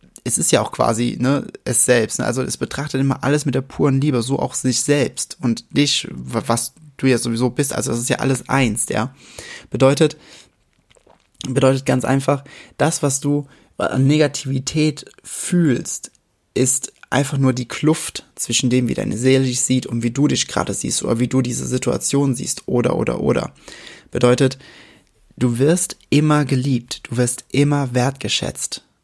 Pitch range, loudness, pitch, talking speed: 125-145 Hz, -19 LUFS, 135 Hz, 170 wpm